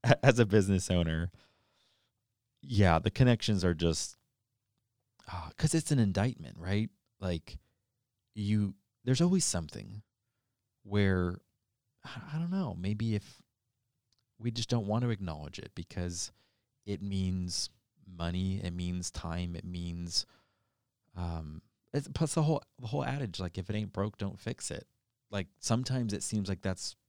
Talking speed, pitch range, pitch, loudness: 140 wpm, 95-120 Hz, 105 Hz, -33 LUFS